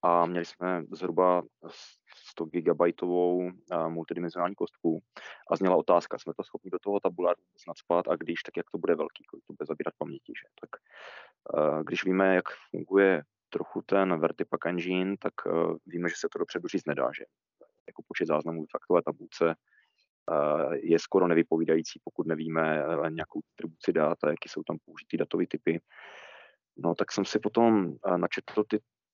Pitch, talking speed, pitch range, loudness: 90 Hz, 170 wpm, 85-100 Hz, -29 LUFS